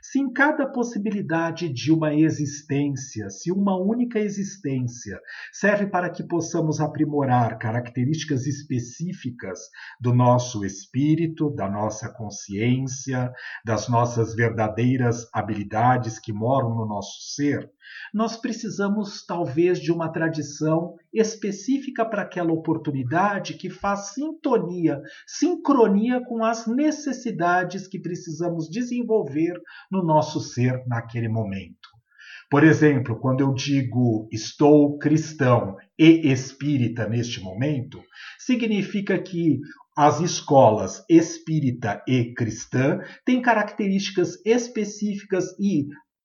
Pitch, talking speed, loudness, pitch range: 155 Hz, 105 wpm, -23 LUFS, 125-195 Hz